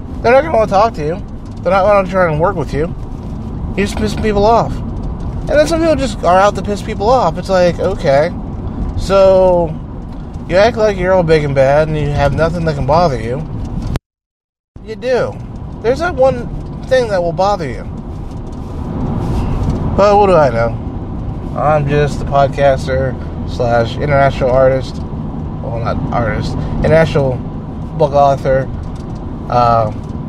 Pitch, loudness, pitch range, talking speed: 145 Hz, -14 LUFS, 120-185 Hz, 165 wpm